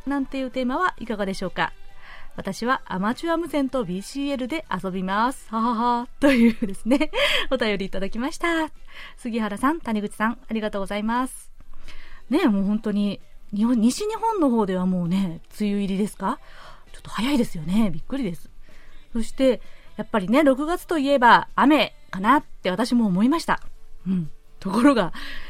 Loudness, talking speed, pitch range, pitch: -23 LUFS, 345 characters per minute, 200-275 Hz, 230 Hz